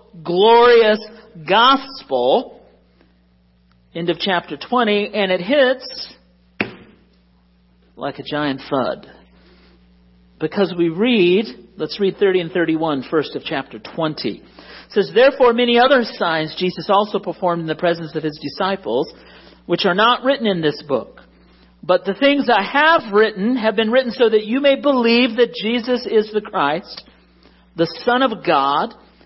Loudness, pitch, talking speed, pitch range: -17 LUFS, 185 Hz, 145 wpm, 150-235 Hz